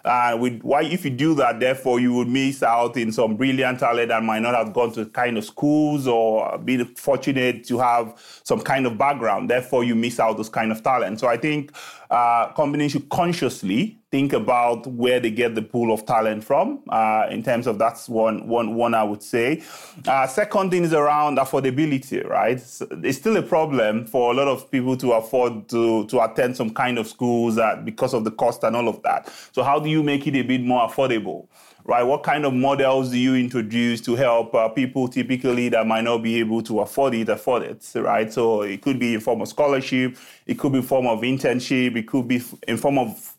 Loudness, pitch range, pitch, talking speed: -21 LUFS, 115-135 Hz, 125 Hz, 220 wpm